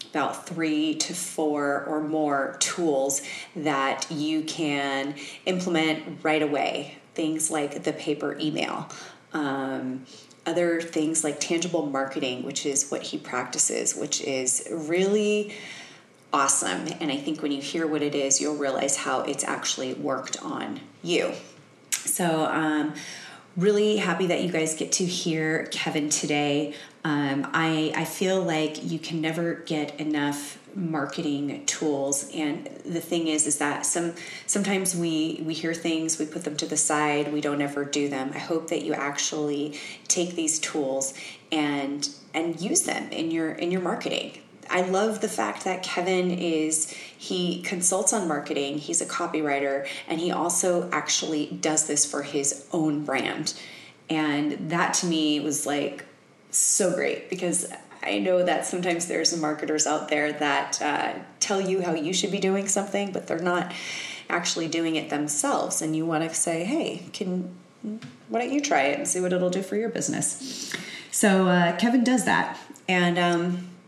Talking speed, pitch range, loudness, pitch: 160 wpm, 145-175 Hz, -26 LUFS, 155 Hz